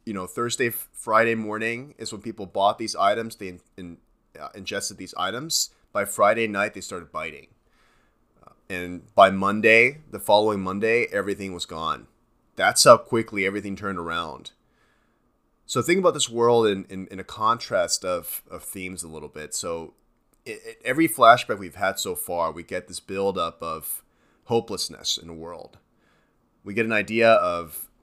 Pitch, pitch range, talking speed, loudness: 105 Hz, 95-115 Hz, 170 wpm, -23 LUFS